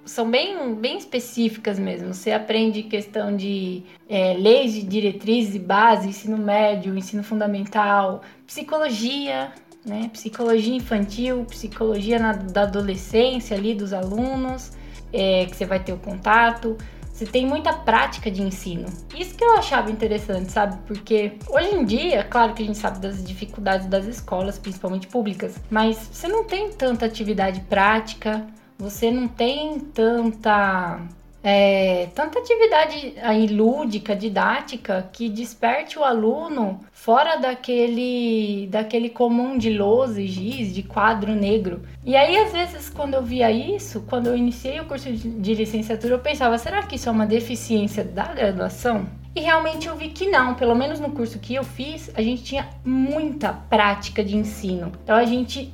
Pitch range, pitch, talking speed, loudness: 205-250 Hz, 225 Hz, 155 wpm, -22 LUFS